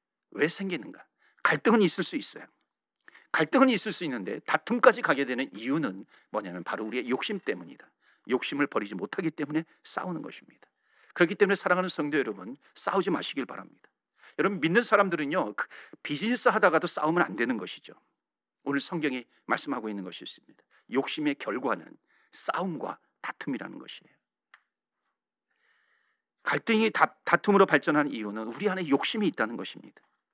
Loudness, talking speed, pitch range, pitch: -28 LUFS, 365 characters per minute, 145-225 Hz, 180 Hz